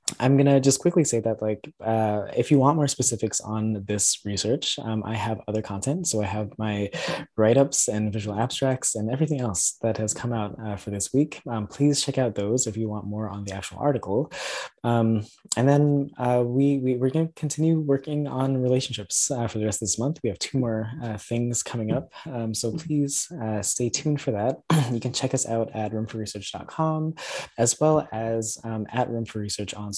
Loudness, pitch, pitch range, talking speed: -25 LUFS, 115 Hz, 110-140 Hz, 210 wpm